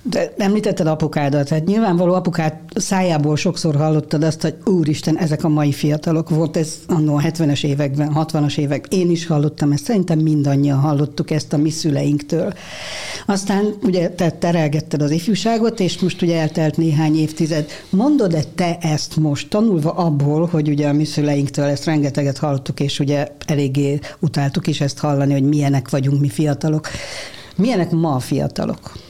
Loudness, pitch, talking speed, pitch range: -18 LUFS, 155 Hz, 155 wpm, 145-170 Hz